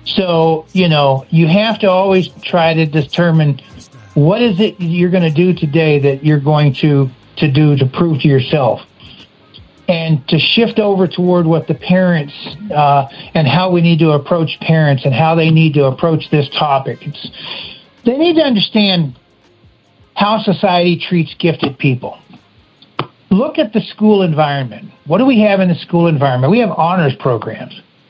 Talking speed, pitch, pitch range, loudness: 170 wpm, 165 Hz, 145-185 Hz, -13 LUFS